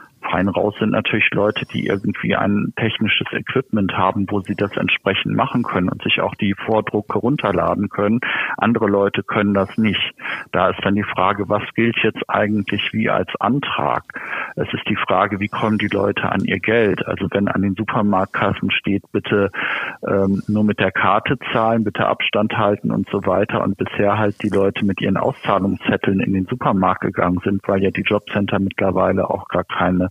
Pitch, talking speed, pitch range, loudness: 100 Hz, 185 wpm, 95-105 Hz, -19 LUFS